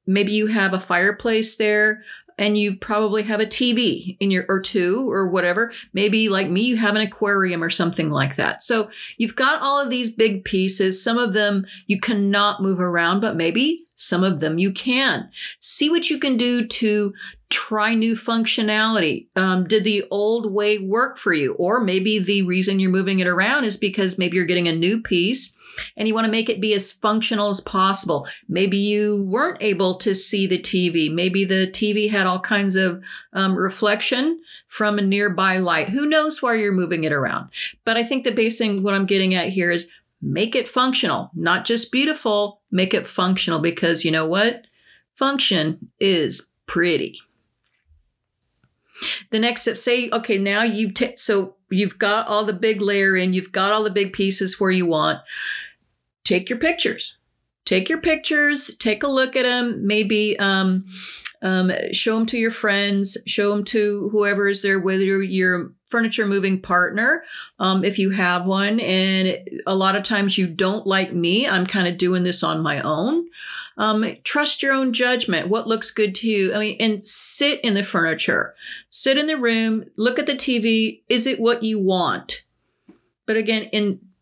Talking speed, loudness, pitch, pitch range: 185 wpm, -20 LUFS, 205 Hz, 190-225 Hz